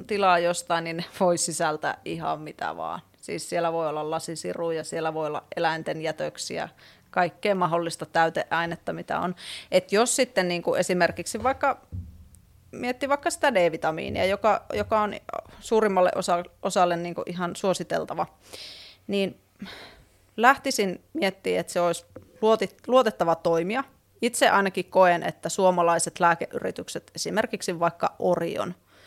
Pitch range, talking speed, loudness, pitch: 165-205 Hz, 125 wpm, -25 LUFS, 175 Hz